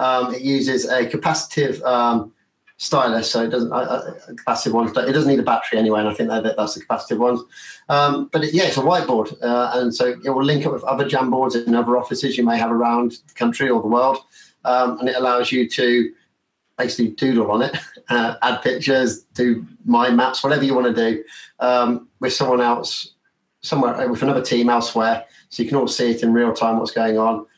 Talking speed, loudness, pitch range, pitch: 215 wpm, -19 LUFS, 115-130 Hz, 125 Hz